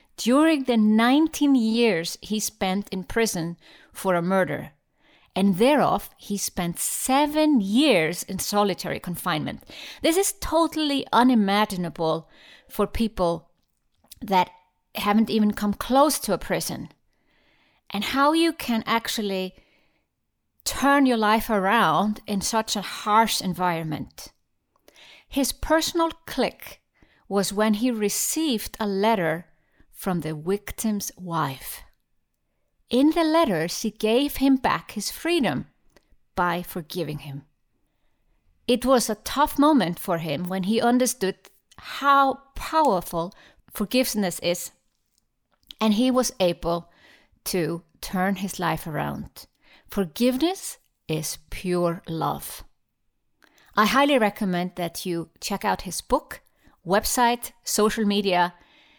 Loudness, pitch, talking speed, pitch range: -24 LUFS, 210 Hz, 115 wpm, 180-255 Hz